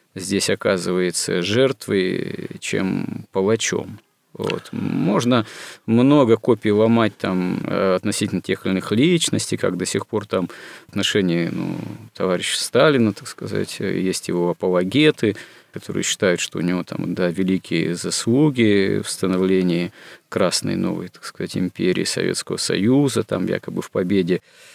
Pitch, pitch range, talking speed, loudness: 95 Hz, 90-115 Hz, 125 wpm, -20 LUFS